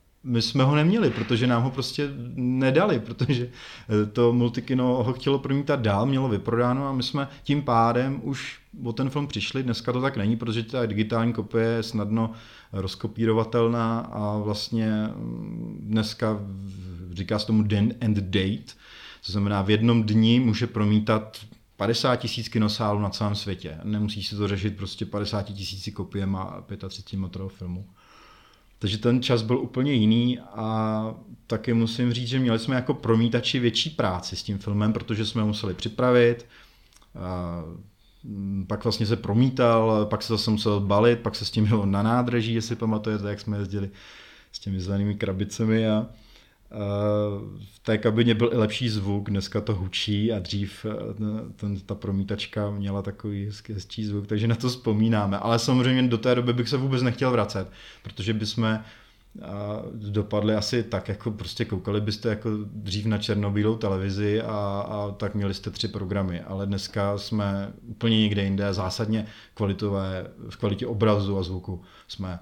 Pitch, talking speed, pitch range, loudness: 110 Hz, 155 wpm, 100-120 Hz, -25 LUFS